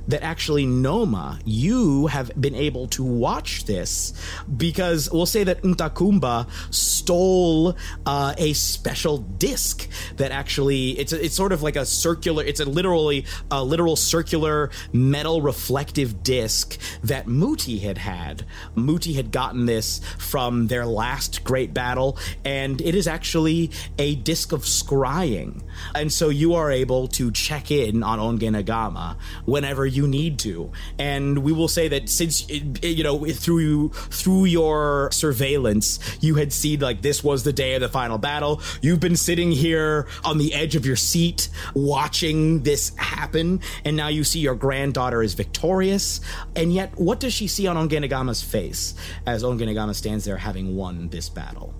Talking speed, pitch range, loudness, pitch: 160 wpm, 110-160 Hz, -22 LUFS, 140 Hz